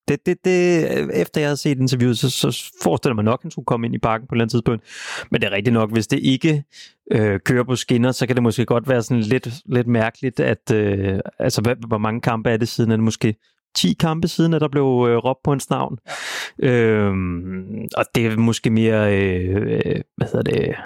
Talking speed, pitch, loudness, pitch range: 230 wpm, 120 Hz, -20 LUFS, 110-140 Hz